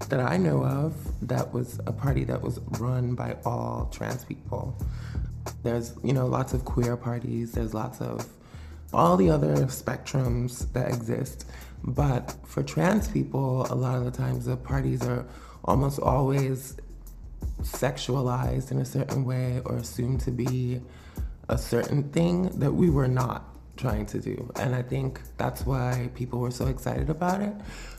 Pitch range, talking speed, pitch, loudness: 120-130 Hz, 160 wpm, 125 Hz, -28 LUFS